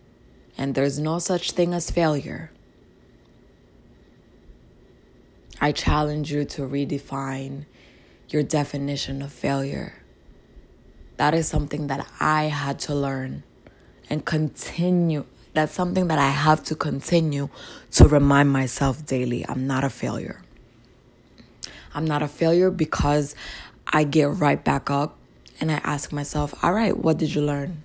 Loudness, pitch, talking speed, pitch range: -23 LUFS, 145 Hz, 130 wpm, 135-155 Hz